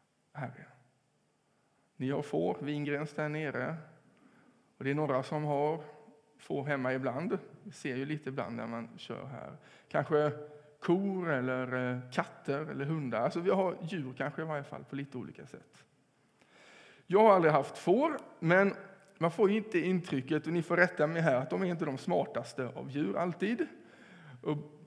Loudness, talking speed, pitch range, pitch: -33 LUFS, 165 wpm, 140-180 Hz, 150 Hz